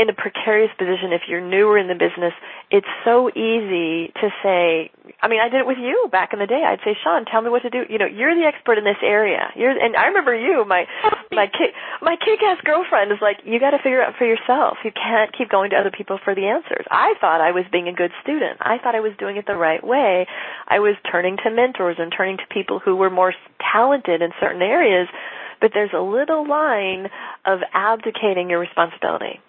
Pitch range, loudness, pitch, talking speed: 185-250 Hz, -19 LUFS, 210 Hz, 235 wpm